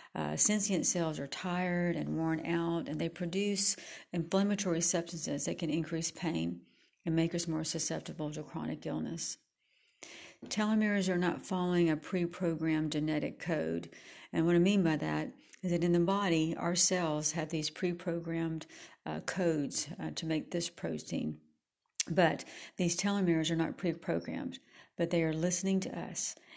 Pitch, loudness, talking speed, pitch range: 170 Hz, -33 LUFS, 150 wpm, 160-180 Hz